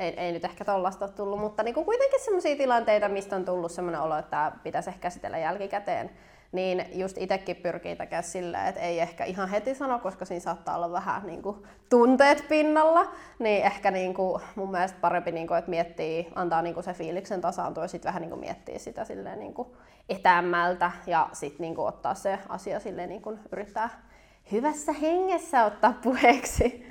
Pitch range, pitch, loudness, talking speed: 175-240 Hz, 195 Hz, -28 LUFS, 175 wpm